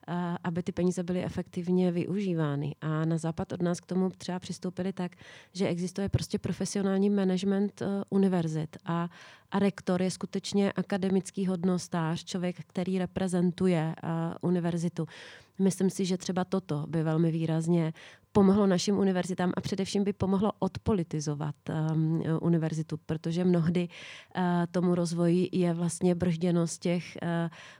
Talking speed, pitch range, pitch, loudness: 125 wpm, 165-190 Hz, 180 Hz, -30 LUFS